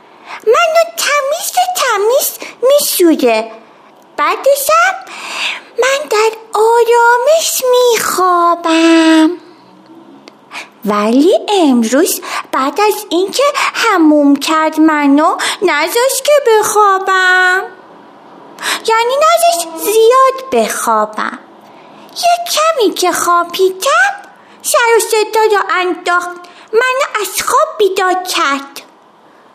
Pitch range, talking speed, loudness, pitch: 320-430 Hz, 85 wpm, -11 LUFS, 360 Hz